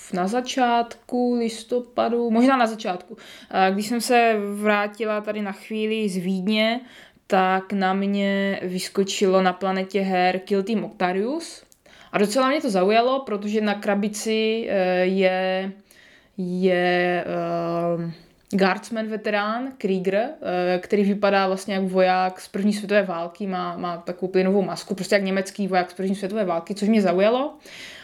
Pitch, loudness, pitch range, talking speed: 200 Hz, -23 LUFS, 185-220 Hz, 135 wpm